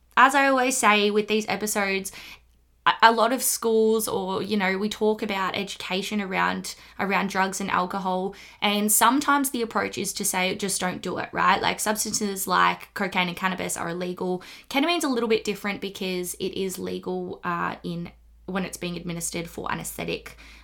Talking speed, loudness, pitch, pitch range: 175 wpm, -24 LUFS, 195 Hz, 180-215 Hz